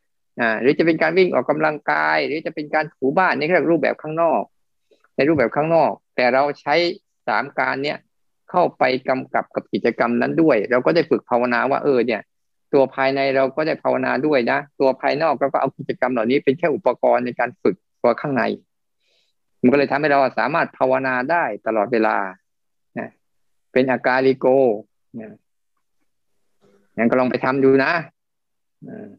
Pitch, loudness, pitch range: 130 Hz, -19 LUFS, 125-150 Hz